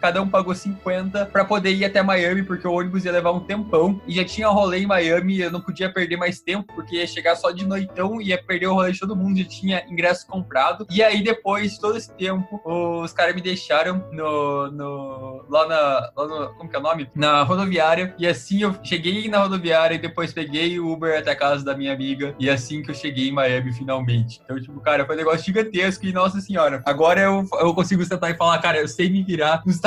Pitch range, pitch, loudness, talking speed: 155-190 Hz, 175 Hz, -21 LUFS, 235 wpm